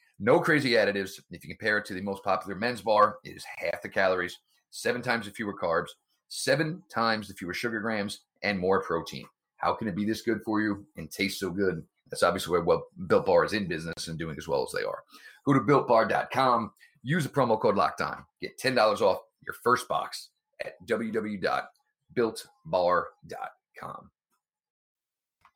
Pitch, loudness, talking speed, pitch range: 110 Hz, -28 LUFS, 180 wpm, 100-165 Hz